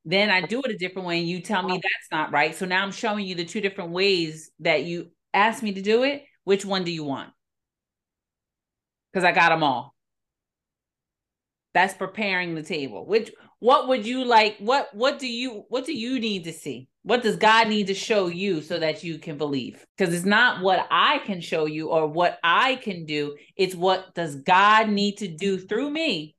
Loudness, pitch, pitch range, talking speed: -23 LUFS, 190 Hz, 170-220 Hz, 210 wpm